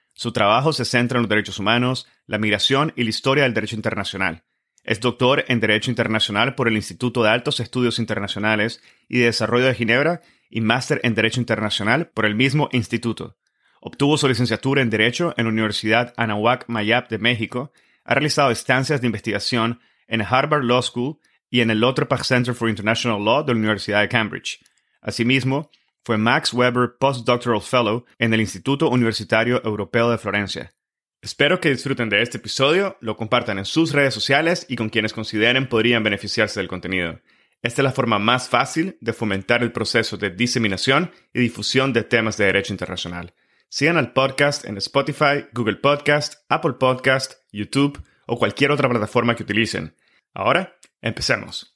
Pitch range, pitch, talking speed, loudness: 110-130 Hz, 120 Hz, 170 wpm, -20 LUFS